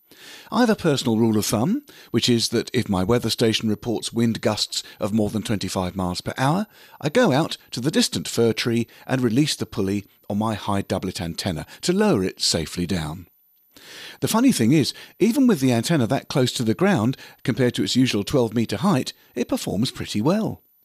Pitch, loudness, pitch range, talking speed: 115 Hz, -22 LUFS, 105-130 Hz, 205 wpm